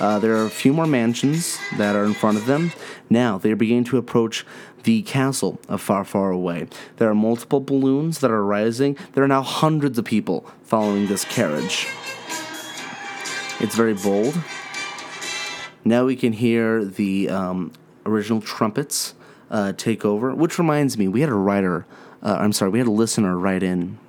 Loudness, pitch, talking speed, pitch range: -21 LUFS, 115 Hz, 175 wpm, 100-135 Hz